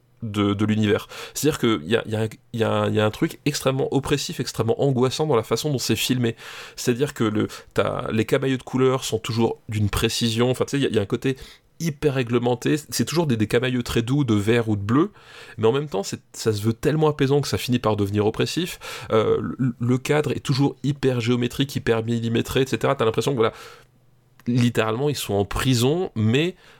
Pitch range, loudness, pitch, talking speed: 115-140 Hz, -22 LUFS, 125 Hz, 210 wpm